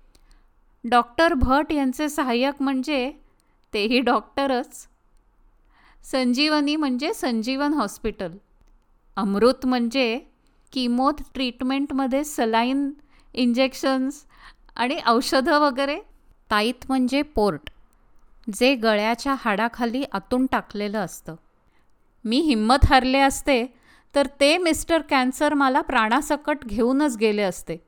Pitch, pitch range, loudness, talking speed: 260 Hz, 235-285 Hz, -22 LUFS, 90 wpm